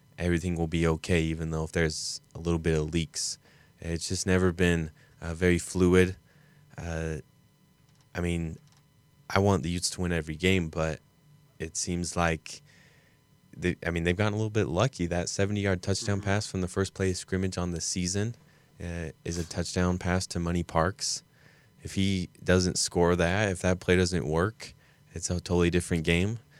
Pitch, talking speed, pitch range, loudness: 90 Hz, 185 wpm, 85-100 Hz, -29 LUFS